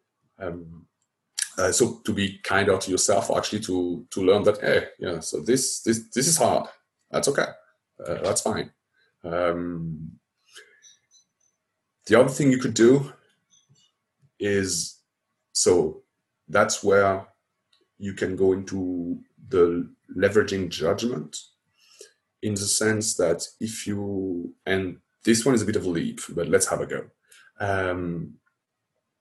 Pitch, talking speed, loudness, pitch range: 95 Hz, 135 wpm, -24 LUFS, 90-110 Hz